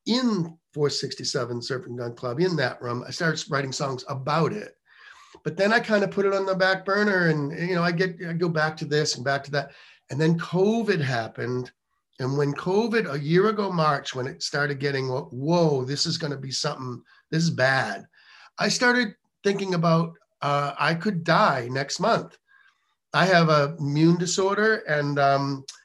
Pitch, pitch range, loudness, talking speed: 160 Hz, 140-190 Hz, -24 LUFS, 190 wpm